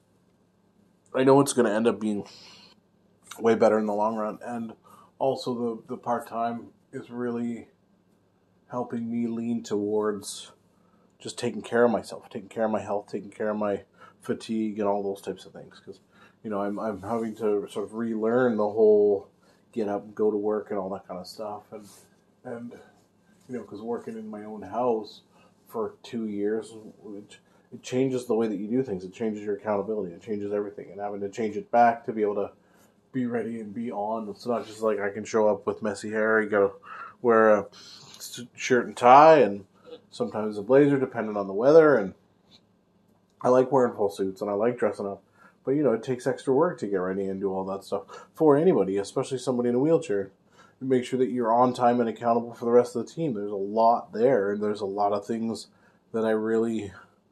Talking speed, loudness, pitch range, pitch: 210 wpm, -26 LUFS, 105-120 Hz, 110 Hz